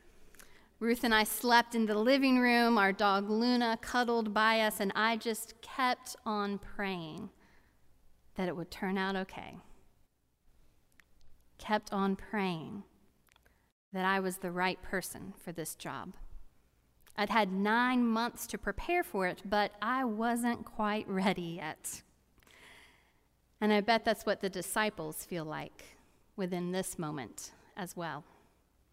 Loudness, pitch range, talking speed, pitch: -32 LUFS, 185-230 Hz, 135 wpm, 210 Hz